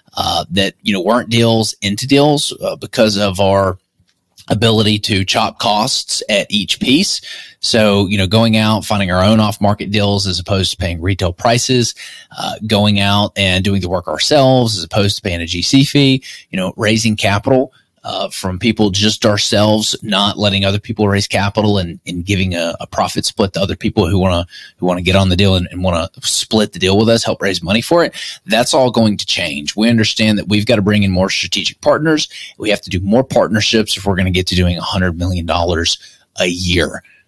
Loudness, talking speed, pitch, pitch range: -14 LUFS, 210 wpm, 100 Hz, 95-110 Hz